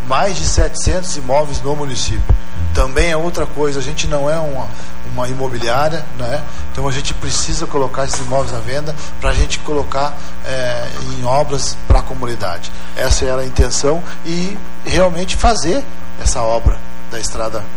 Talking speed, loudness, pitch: 160 wpm, -18 LUFS, 130 Hz